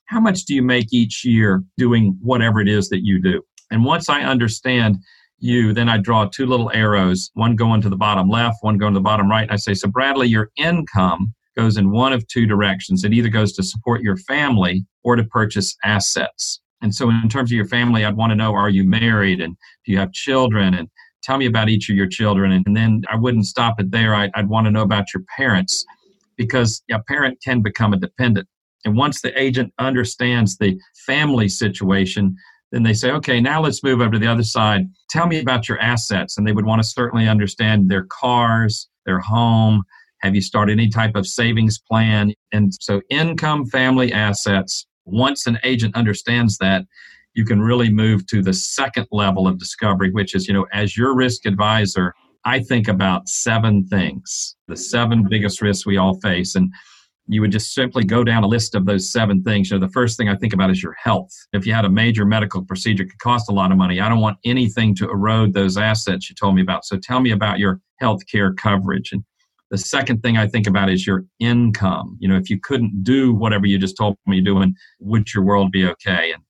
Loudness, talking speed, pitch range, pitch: -18 LUFS, 220 wpm, 100-120 Hz, 110 Hz